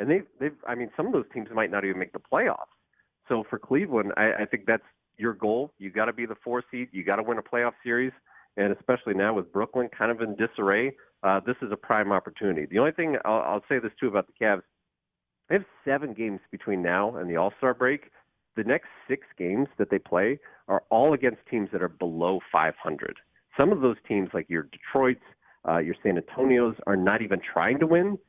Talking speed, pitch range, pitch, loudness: 225 wpm, 100-125 Hz, 115 Hz, -27 LUFS